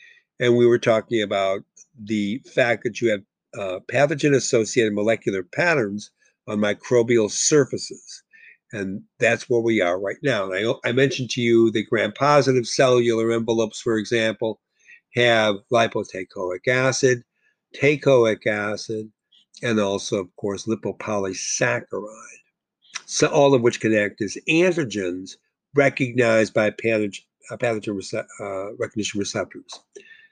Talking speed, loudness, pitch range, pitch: 115 wpm, -21 LUFS, 105-135 Hz, 115 Hz